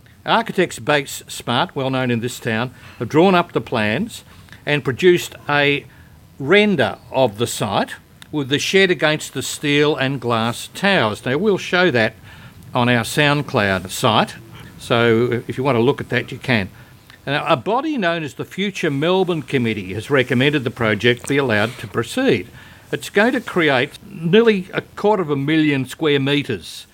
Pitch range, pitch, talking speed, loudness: 120-160 Hz, 135 Hz, 170 wpm, -18 LUFS